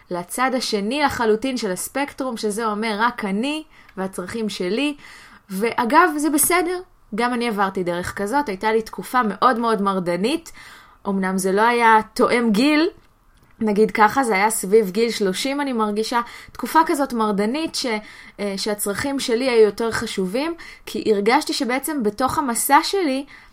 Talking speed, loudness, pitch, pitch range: 140 wpm, -20 LUFS, 230 Hz, 210-275 Hz